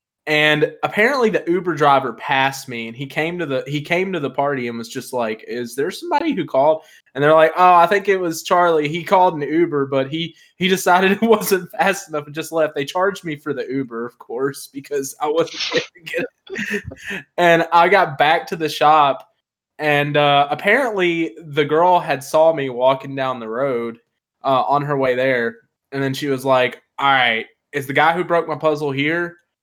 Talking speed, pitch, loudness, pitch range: 210 wpm, 155 Hz, -18 LUFS, 135-175 Hz